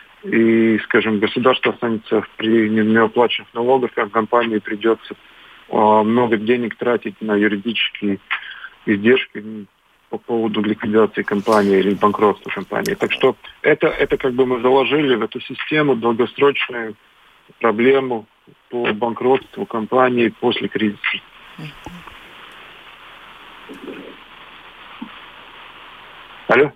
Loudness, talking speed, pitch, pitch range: -18 LUFS, 95 wpm, 115 Hz, 105-125 Hz